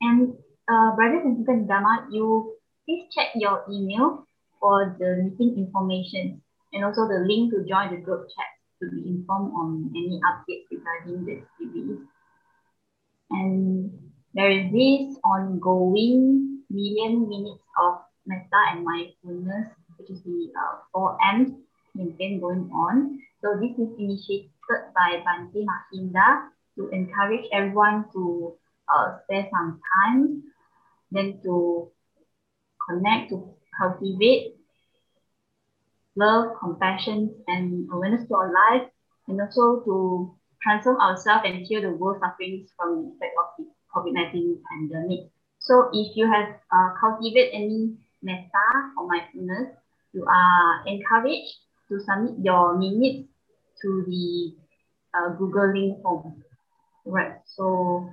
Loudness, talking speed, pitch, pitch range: -23 LUFS, 125 wpm, 195 Hz, 180-225 Hz